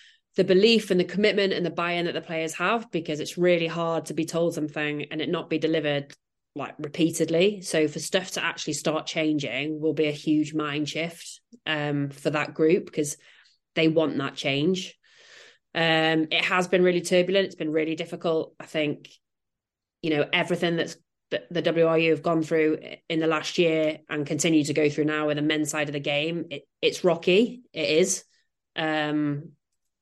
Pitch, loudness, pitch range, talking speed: 160 Hz, -25 LUFS, 155-175 Hz, 190 wpm